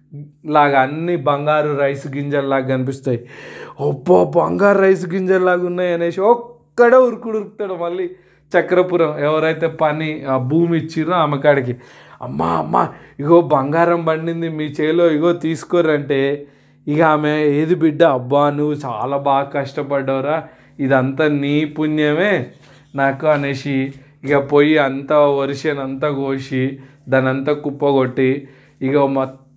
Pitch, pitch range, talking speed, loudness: 150 Hz, 140-165 Hz, 115 wpm, -17 LUFS